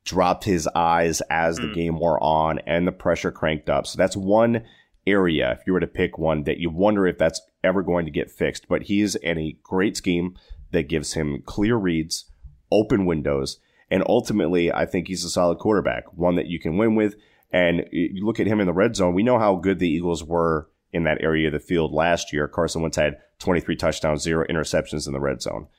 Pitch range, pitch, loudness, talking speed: 80-90 Hz, 85 Hz, -22 LUFS, 220 wpm